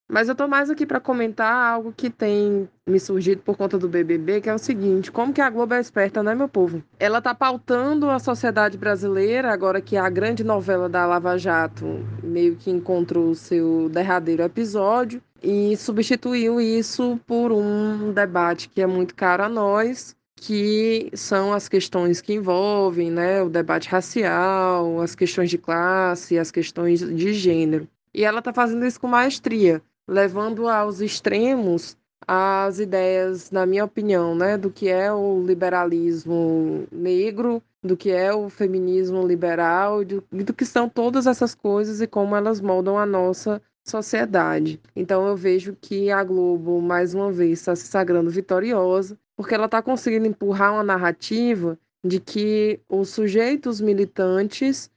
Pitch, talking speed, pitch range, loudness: 195 Hz, 160 wpm, 180-220 Hz, -21 LUFS